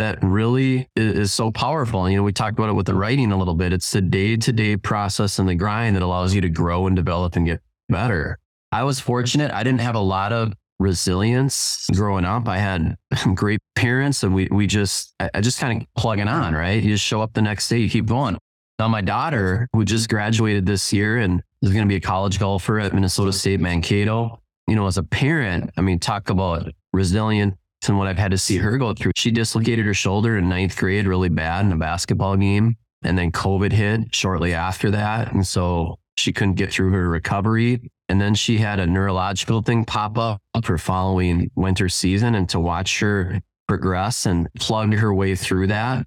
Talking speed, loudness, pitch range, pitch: 215 wpm, -20 LUFS, 95-115 Hz, 100 Hz